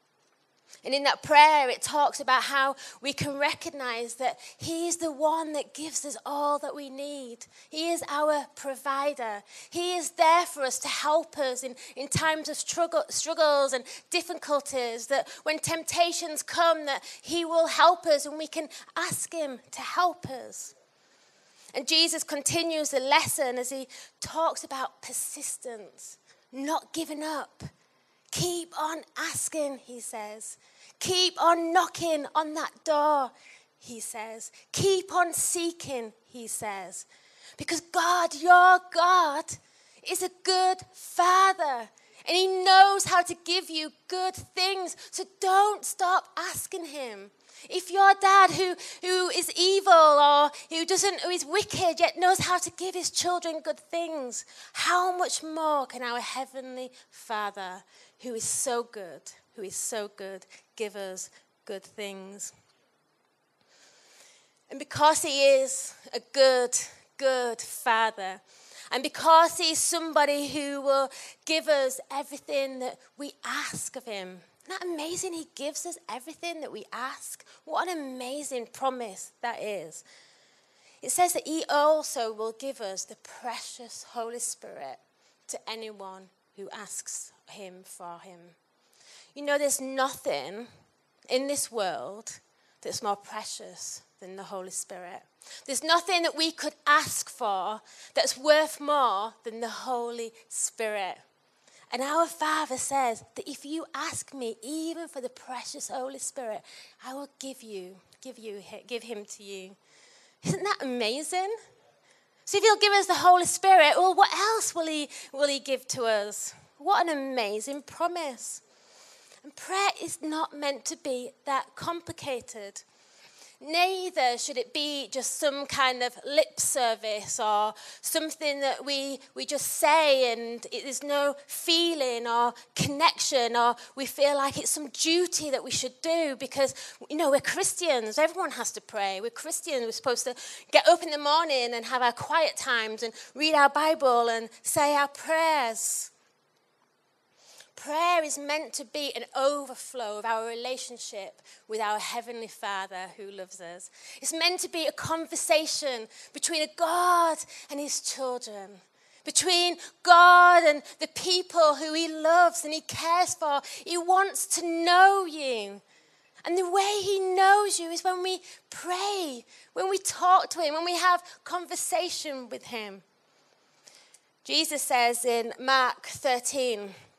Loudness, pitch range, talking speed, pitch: -26 LUFS, 245-335 Hz, 150 wpm, 290 Hz